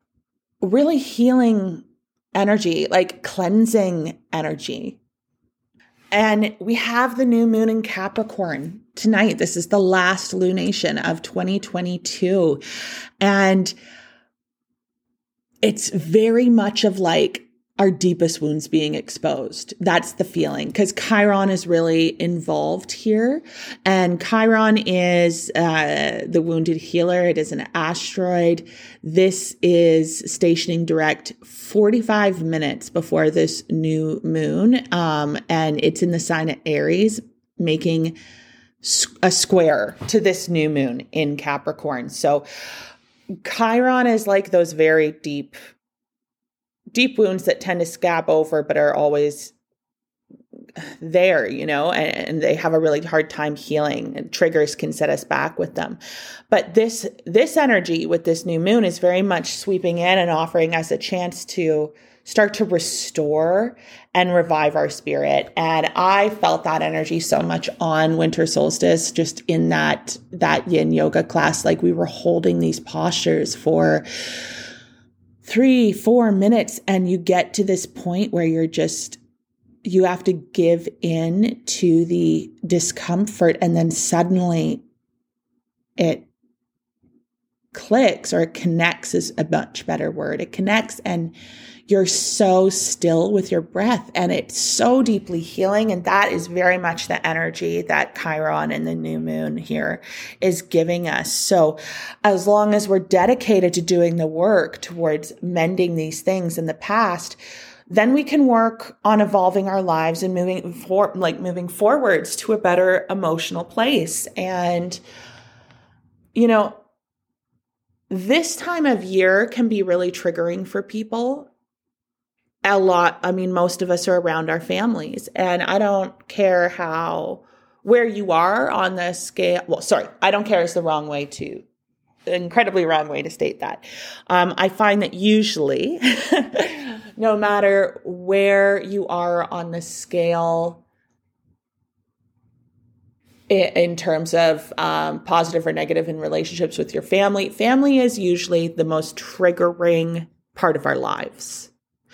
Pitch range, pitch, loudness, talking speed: 160-210 Hz, 180 Hz, -19 LUFS, 140 wpm